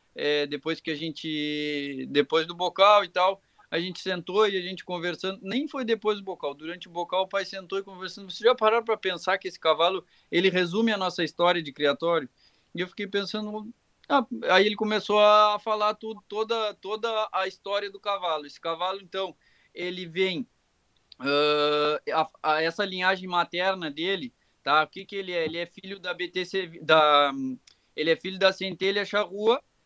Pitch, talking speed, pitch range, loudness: 185 Hz, 185 wpm, 165-205 Hz, -26 LUFS